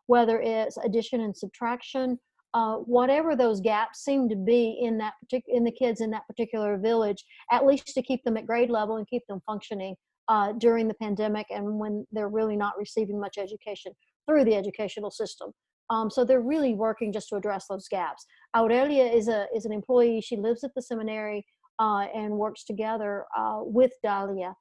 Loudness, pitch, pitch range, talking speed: -27 LUFS, 225 Hz, 210-245 Hz, 190 wpm